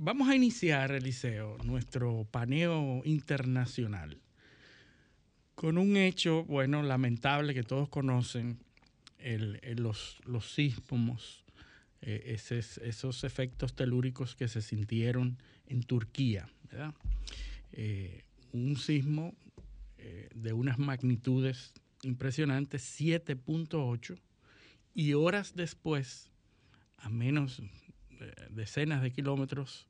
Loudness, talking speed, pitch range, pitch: -34 LUFS, 100 wpm, 115-145 Hz, 130 Hz